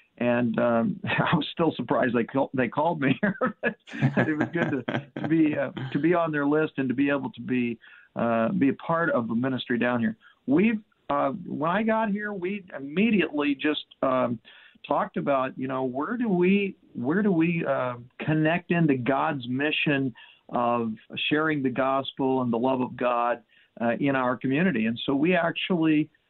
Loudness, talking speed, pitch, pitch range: -26 LUFS, 185 wpm, 140 Hz, 125-170 Hz